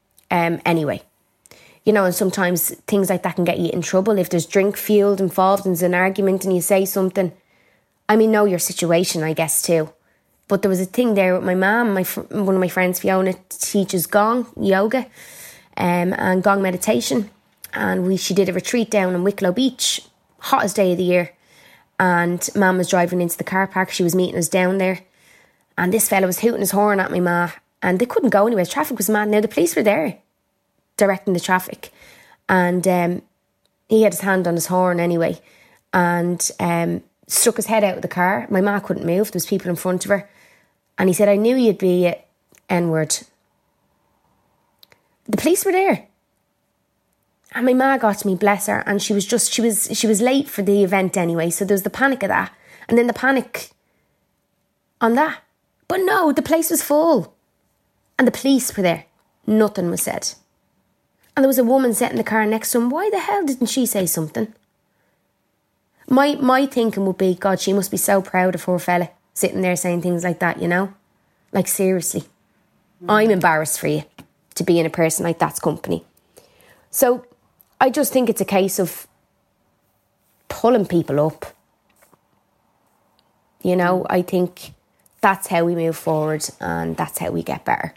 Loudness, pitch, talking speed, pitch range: -19 LUFS, 190 Hz, 195 wpm, 180-215 Hz